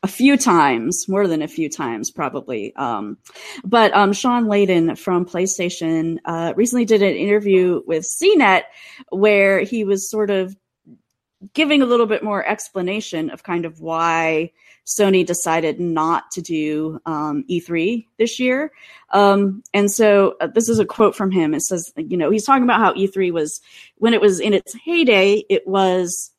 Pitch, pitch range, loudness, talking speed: 195 Hz, 170-220 Hz, -18 LUFS, 170 wpm